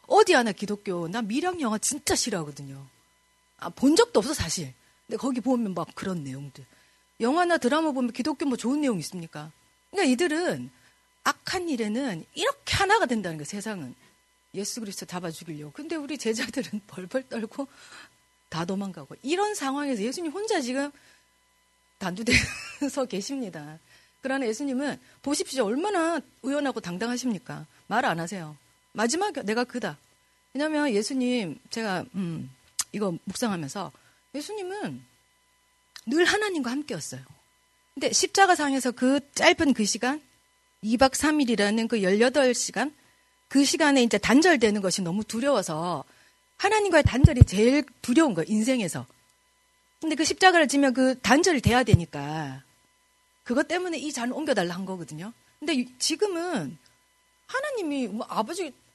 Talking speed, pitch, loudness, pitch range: 315 characters per minute, 245 Hz, -26 LUFS, 190-290 Hz